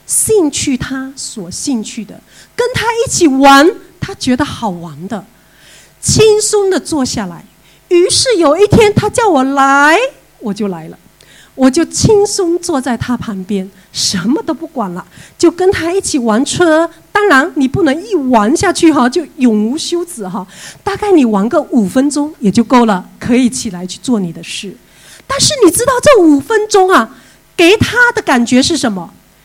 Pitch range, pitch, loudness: 230-360 Hz, 280 Hz, -11 LUFS